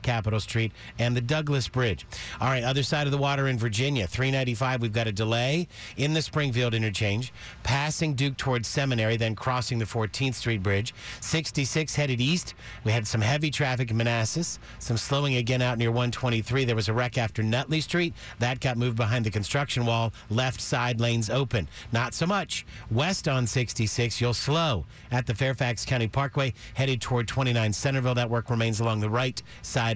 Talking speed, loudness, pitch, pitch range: 185 wpm, -27 LUFS, 120 Hz, 115-135 Hz